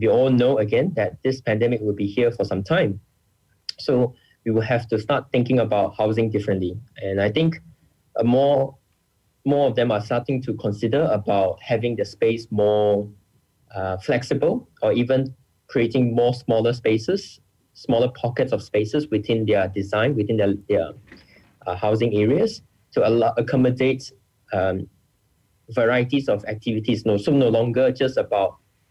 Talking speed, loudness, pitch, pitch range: 150 wpm, -22 LUFS, 115 Hz, 105-125 Hz